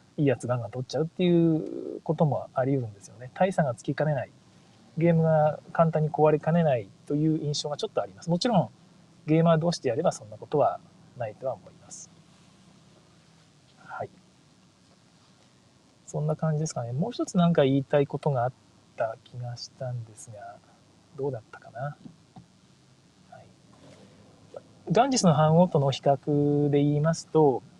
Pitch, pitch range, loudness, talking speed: 155 Hz, 140-170 Hz, -26 LUFS, 340 characters per minute